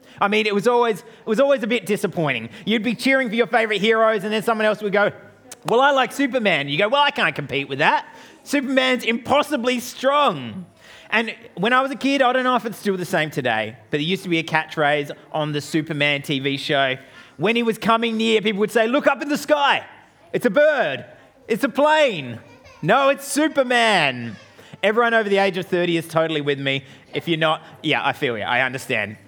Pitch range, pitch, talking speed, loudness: 150-250 Hz, 210 Hz, 220 wpm, -20 LUFS